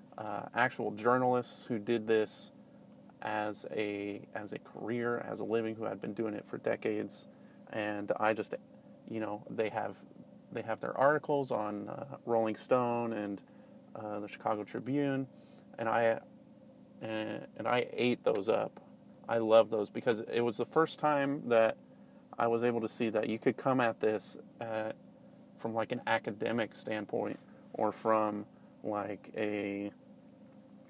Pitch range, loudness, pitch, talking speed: 105-120 Hz, -34 LUFS, 110 Hz, 155 wpm